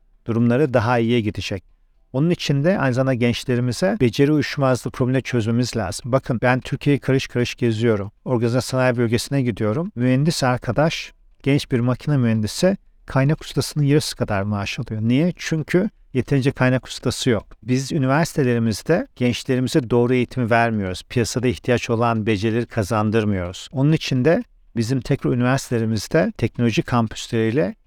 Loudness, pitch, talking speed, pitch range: -20 LUFS, 125 Hz, 135 wpm, 115-135 Hz